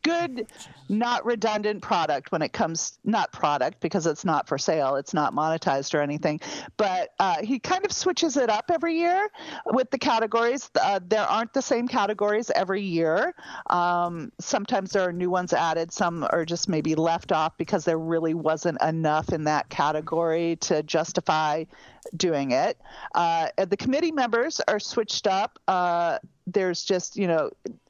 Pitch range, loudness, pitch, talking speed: 165-235 Hz, -25 LUFS, 185 Hz, 165 wpm